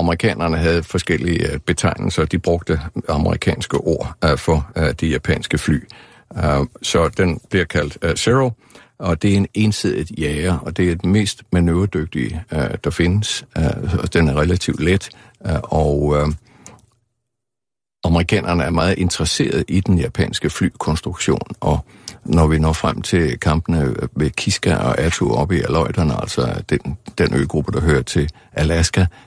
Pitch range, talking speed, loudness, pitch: 80-95 Hz, 135 wpm, -18 LUFS, 85 Hz